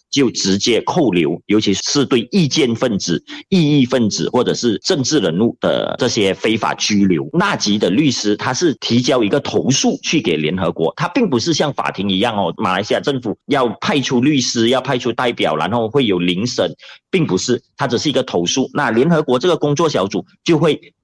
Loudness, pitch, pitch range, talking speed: -16 LUFS, 125 Hz, 105-150 Hz, 295 characters per minute